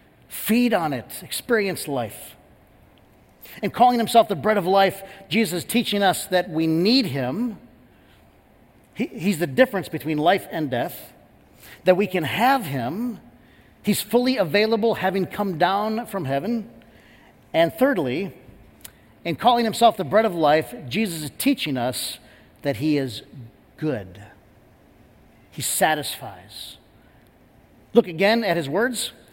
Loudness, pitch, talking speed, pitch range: -22 LUFS, 190 Hz, 135 wpm, 145-220 Hz